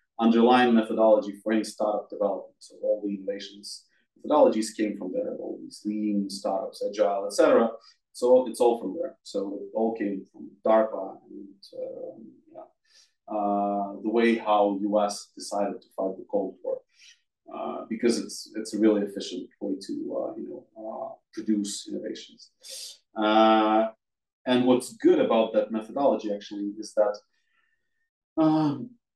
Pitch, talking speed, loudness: 110 Hz, 145 wpm, -26 LUFS